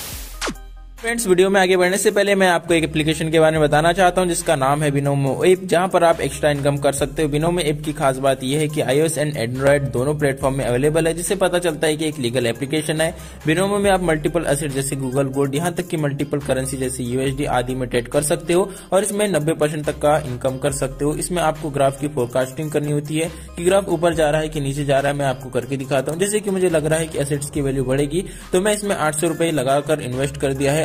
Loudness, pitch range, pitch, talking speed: -19 LUFS, 140-170 Hz, 150 Hz, 250 wpm